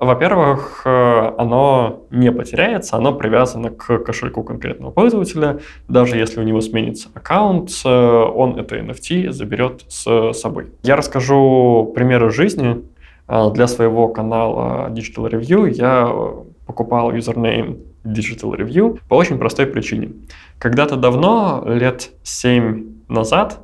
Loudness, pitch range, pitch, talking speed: -16 LUFS, 115-135 Hz, 120 Hz, 115 wpm